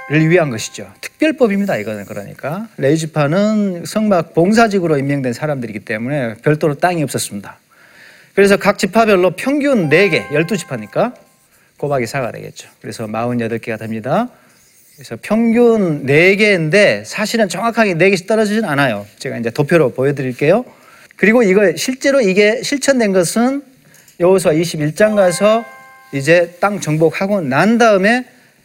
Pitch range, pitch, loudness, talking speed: 140-215 Hz, 175 Hz, -14 LUFS, 320 characters per minute